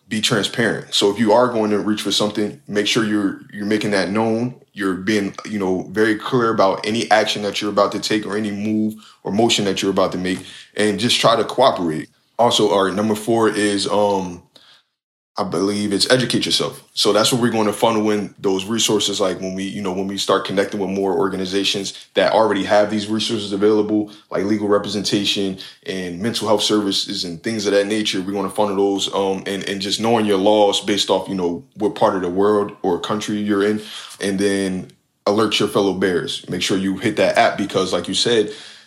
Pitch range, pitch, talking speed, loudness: 100-105 Hz, 105 Hz, 215 wpm, -19 LUFS